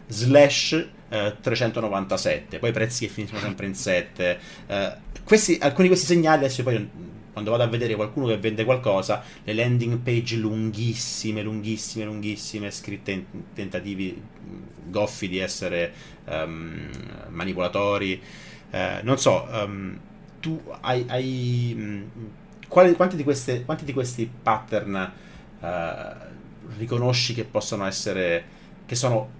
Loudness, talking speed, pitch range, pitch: -24 LUFS, 125 wpm, 105-125 Hz, 110 Hz